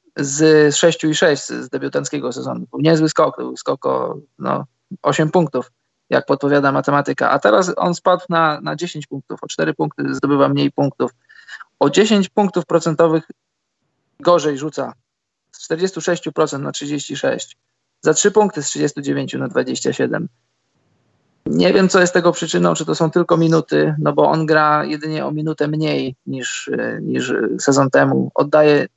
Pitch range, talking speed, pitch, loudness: 105-165 Hz, 150 wpm, 150 Hz, -17 LUFS